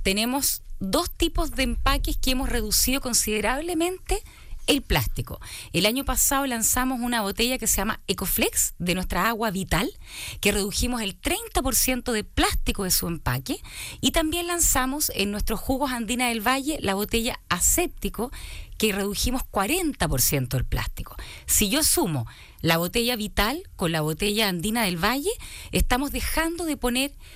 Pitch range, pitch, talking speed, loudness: 195-275 Hz, 235 Hz, 145 wpm, -24 LUFS